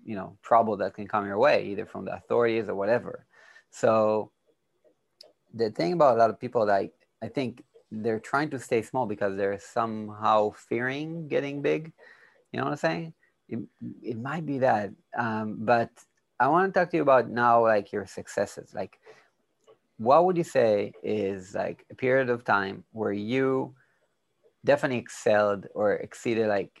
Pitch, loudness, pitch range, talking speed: 115 Hz, -27 LUFS, 105-135 Hz, 170 wpm